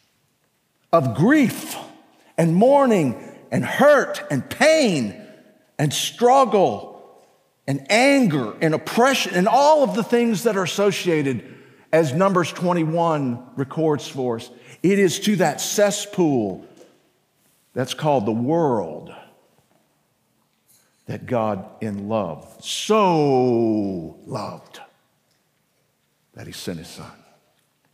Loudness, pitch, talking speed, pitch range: -20 LUFS, 165 Hz, 105 wpm, 130-210 Hz